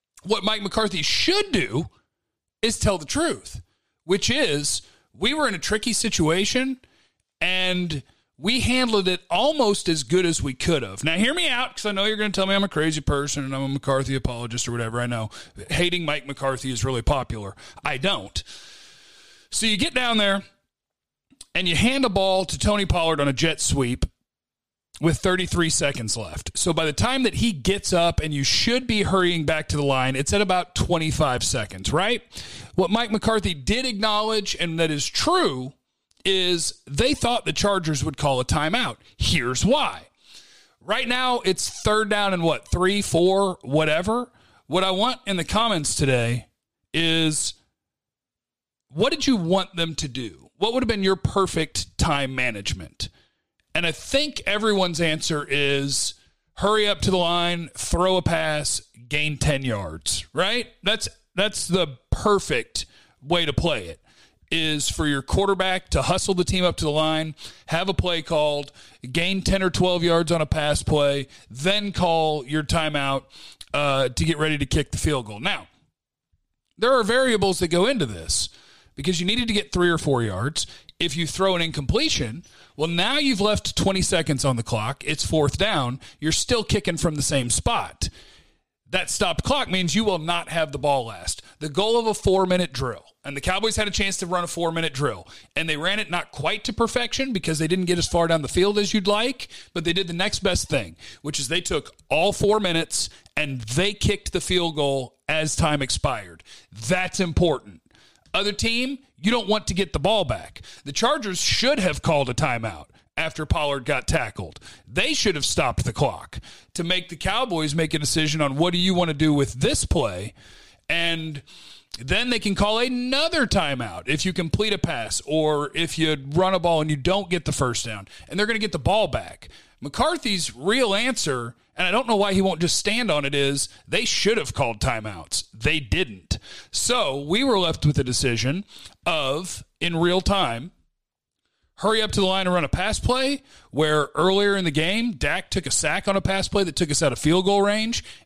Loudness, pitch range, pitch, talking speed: -23 LUFS, 140-195 Hz, 170 Hz, 195 wpm